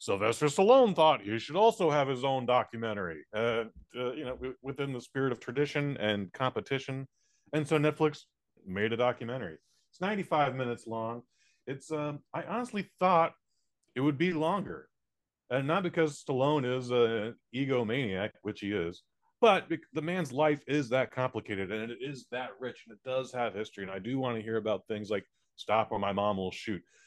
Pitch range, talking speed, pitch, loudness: 115-150 Hz, 180 wpm, 130 Hz, -31 LUFS